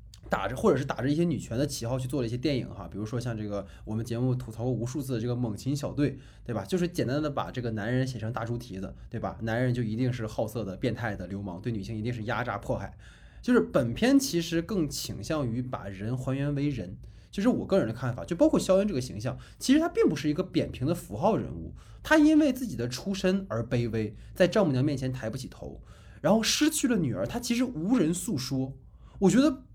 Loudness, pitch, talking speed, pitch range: -29 LUFS, 130 Hz, 355 characters per minute, 115-170 Hz